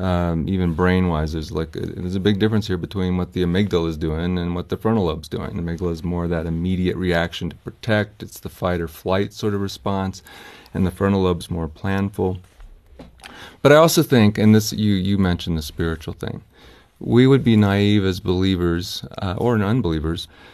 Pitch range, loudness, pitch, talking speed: 85-105 Hz, -20 LUFS, 95 Hz, 195 wpm